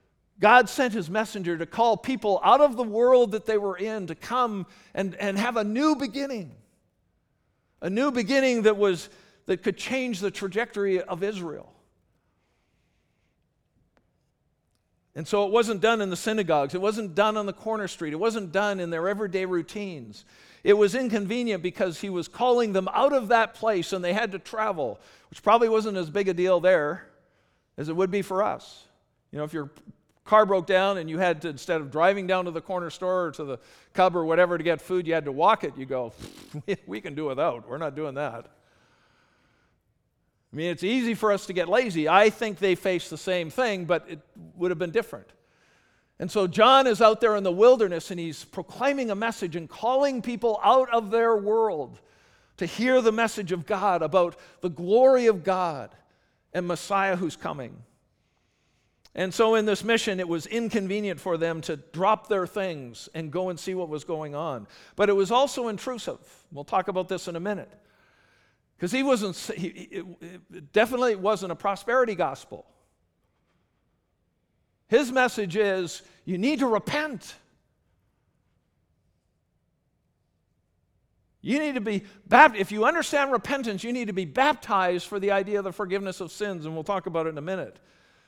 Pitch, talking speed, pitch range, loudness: 195 Hz, 185 wpm, 170-220 Hz, -25 LUFS